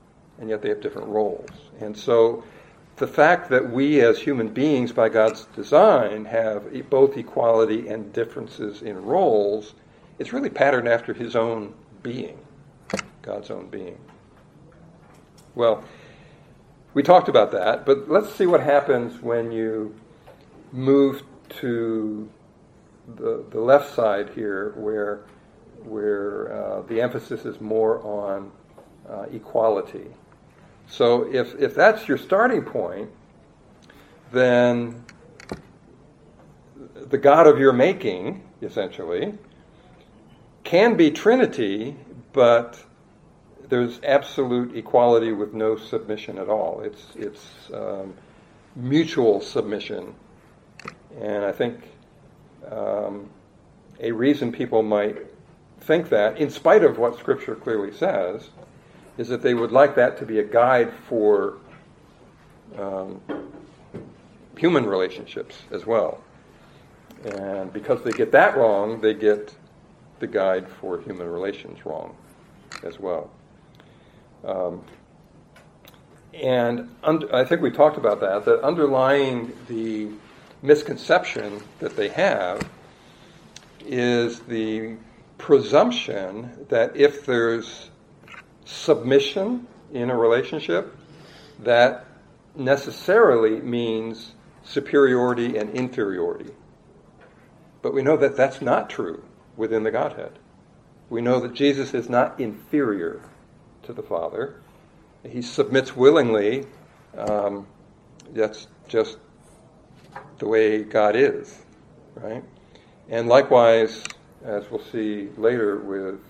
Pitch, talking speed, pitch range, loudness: 120 Hz, 110 wpm, 110-140 Hz, -21 LUFS